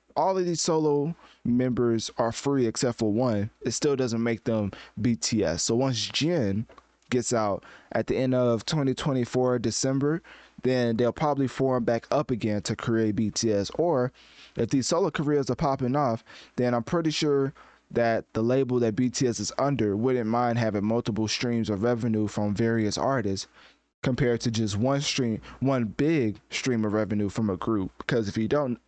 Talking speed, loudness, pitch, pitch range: 170 wpm, -26 LUFS, 120 Hz, 110-135 Hz